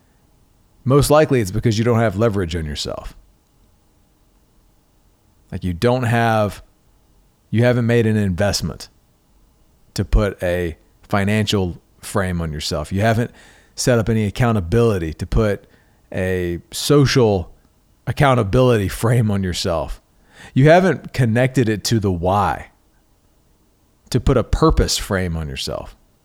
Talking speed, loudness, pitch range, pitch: 125 wpm, -18 LUFS, 95-120 Hz, 105 Hz